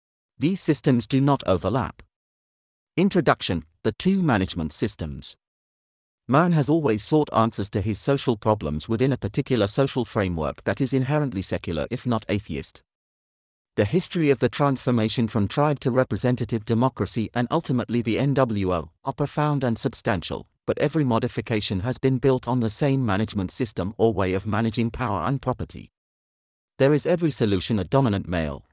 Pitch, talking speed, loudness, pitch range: 120 Hz, 155 wpm, -23 LUFS, 100-135 Hz